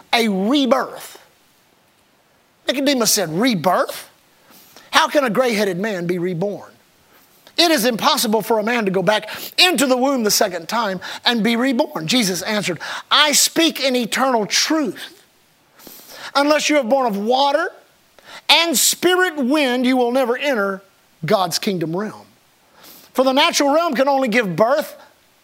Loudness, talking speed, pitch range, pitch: -17 LUFS, 145 wpm, 210-285 Hz, 255 Hz